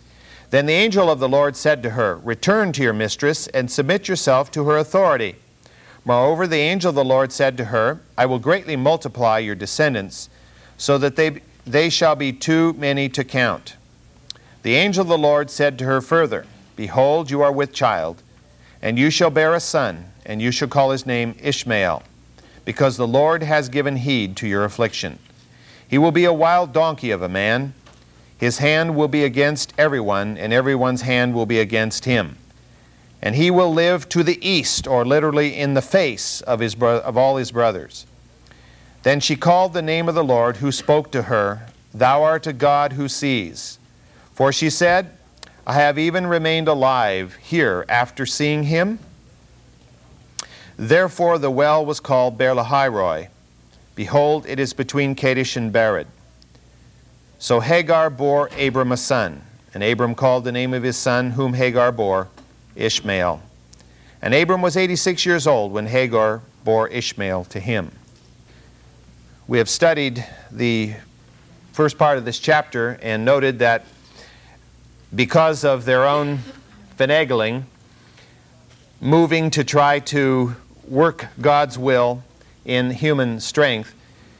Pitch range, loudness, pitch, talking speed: 115-150 Hz, -18 LUFS, 130 Hz, 155 wpm